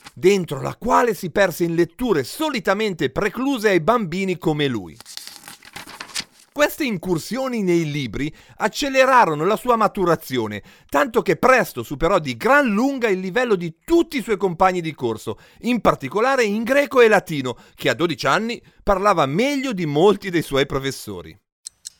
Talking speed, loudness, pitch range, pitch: 145 wpm, -20 LUFS, 150-235 Hz, 190 Hz